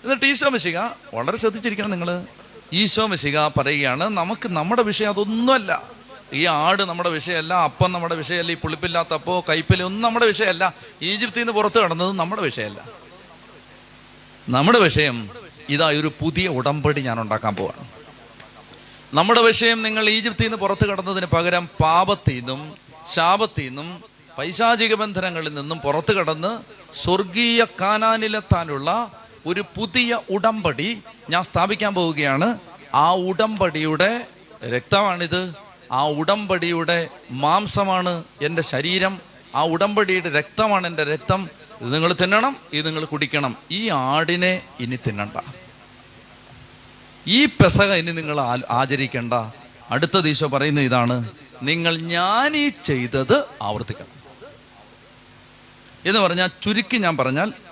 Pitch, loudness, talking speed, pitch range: 175 Hz, -19 LUFS, 110 wpm, 150-210 Hz